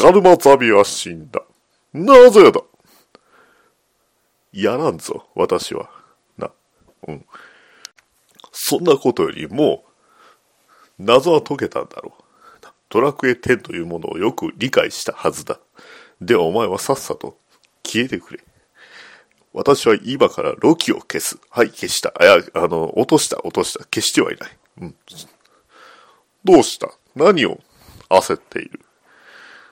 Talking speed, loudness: 240 characters per minute, -16 LUFS